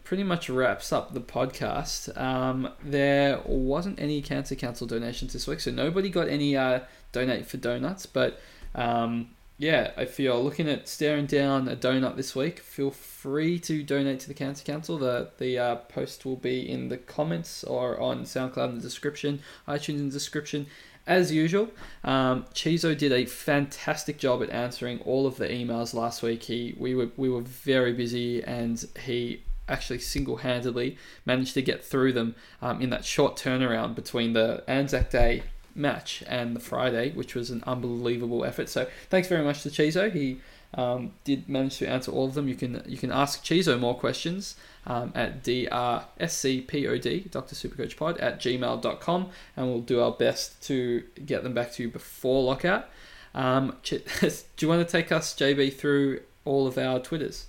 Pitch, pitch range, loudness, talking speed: 130 Hz, 120-145 Hz, -28 LUFS, 175 wpm